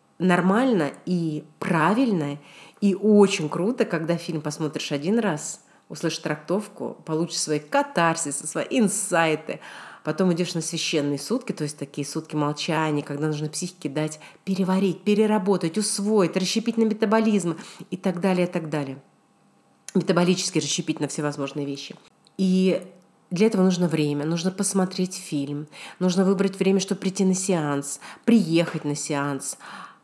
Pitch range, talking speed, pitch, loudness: 150-195 Hz, 135 wpm, 175 Hz, -24 LUFS